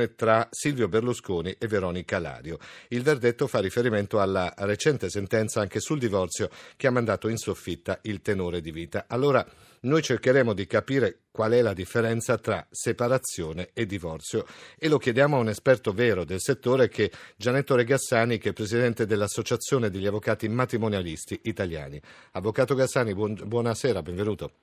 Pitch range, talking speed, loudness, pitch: 100-125 Hz, 155 wpm, -26 LUFS, 110 Hz